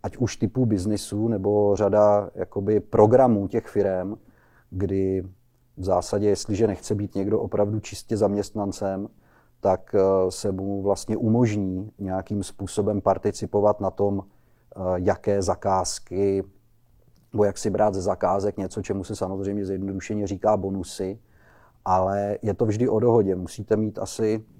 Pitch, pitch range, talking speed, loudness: 100 Hz, 95-105 Hz, 130 wpm, -24 LUFS